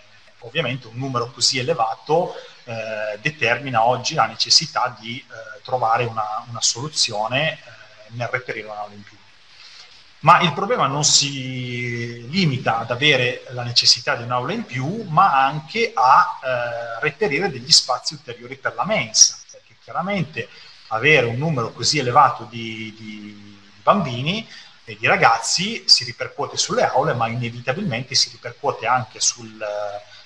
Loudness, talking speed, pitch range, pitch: -19 LUFS, 140 wpm, 115-155 Hz, 125 Hz